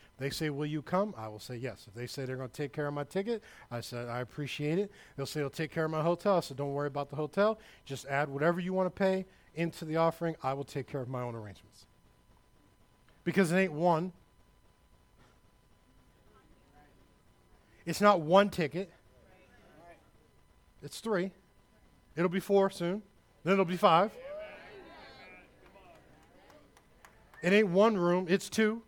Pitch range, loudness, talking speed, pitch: 140-195 Hz, -32 LUFS, 170 wpm, 165 Hz